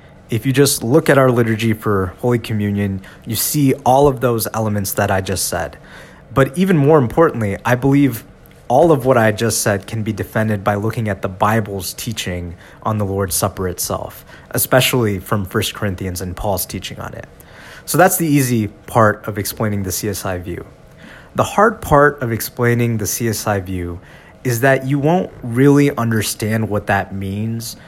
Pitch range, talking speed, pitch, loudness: 100-125 Hz, 175 wpm, 110 Hz, -17 LUFS